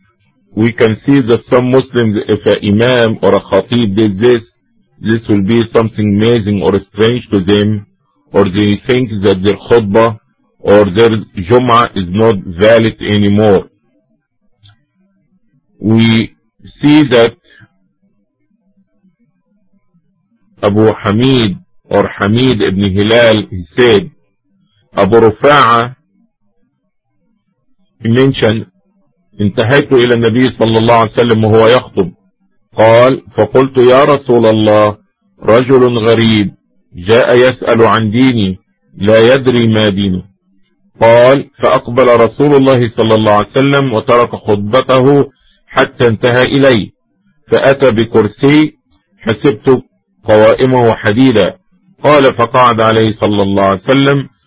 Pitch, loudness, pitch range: 115 Hz, -9 LUFS, 105-130 Hz